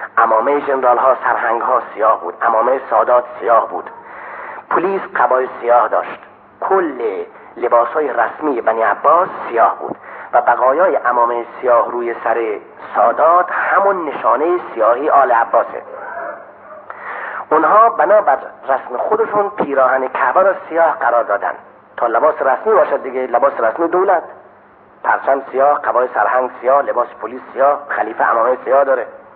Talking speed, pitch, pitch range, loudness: 130 wpm, 130 Hz, 120-170 Hz, -15 LUFS